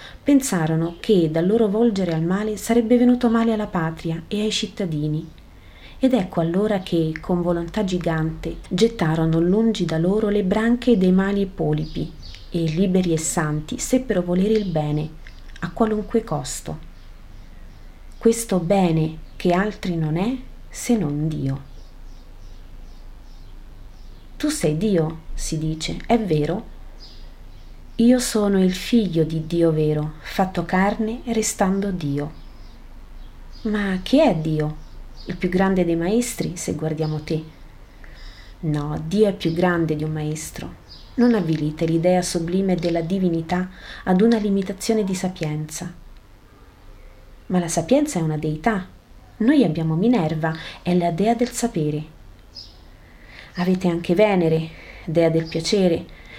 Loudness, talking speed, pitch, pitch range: -21 LUFS, 130 wpm, 175 Hz, 155-210 Hz